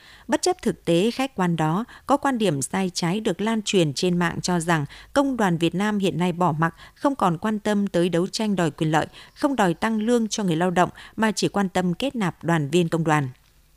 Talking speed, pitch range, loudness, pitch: 240 wpm, 170-220 Hz, -23 LUFS, 180 Hz